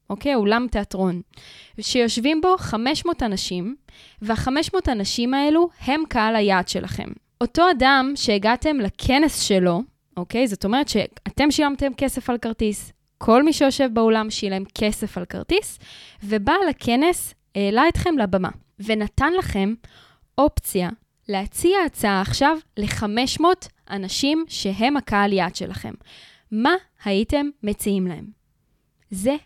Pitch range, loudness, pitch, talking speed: 205-285 Hz, -21 LUFS, 235 Hz, 115 wpm